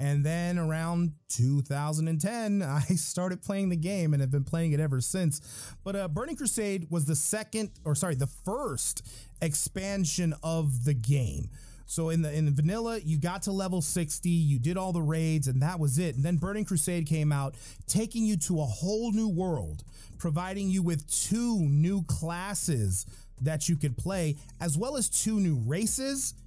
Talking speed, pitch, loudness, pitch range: 180 wpm, 165 Hz, -28 LUFS, 145-190 Hz